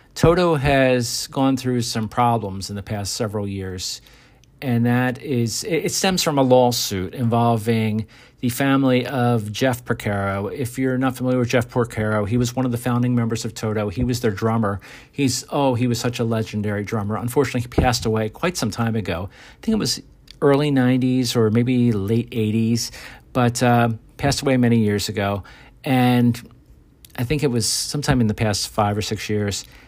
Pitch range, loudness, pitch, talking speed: 110-130 Hz, -21 LUFS, 120 Hz, 185 wpm